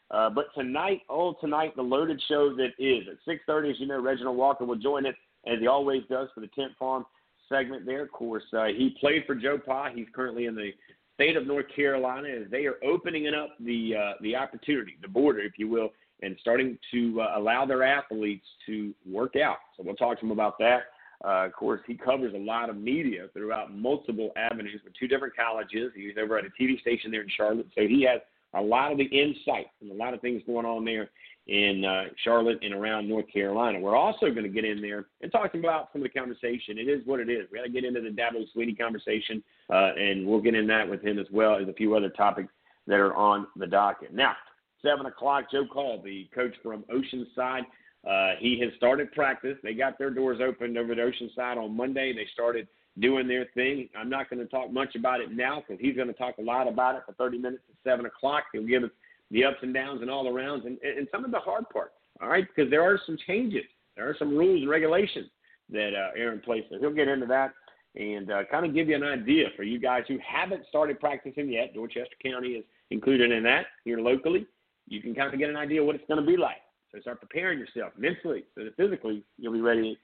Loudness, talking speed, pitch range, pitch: -28 LUFS, 235 wpm, 110-140 Hz, 125 Hz